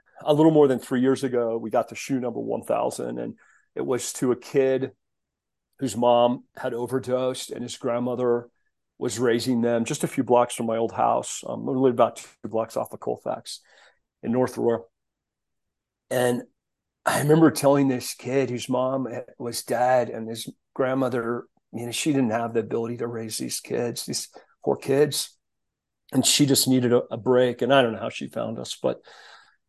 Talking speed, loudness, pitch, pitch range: 190 wpm, -24 LUFS, 125 Hz, 115-130 Hz